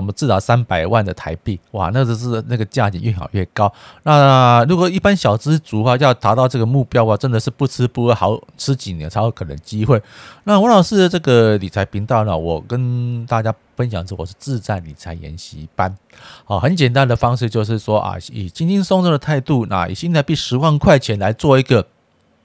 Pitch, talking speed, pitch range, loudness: 115 Hz, 315 characters per minute, 100-135 Hz, -16 LUFS